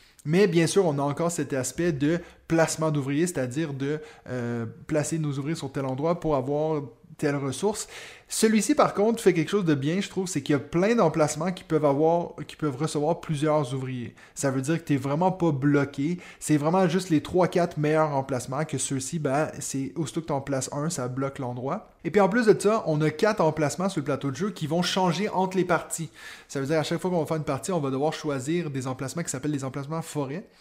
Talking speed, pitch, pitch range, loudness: 235 wpm, 155 Hz, 140-170 Hz, -26 LUFS